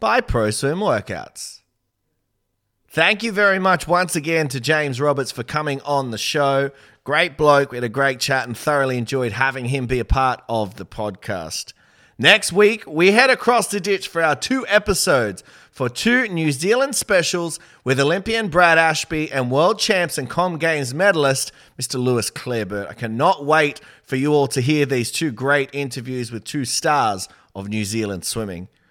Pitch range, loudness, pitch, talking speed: 120-170 Hz, -19 LUFS, 140 Hz, 175 wpm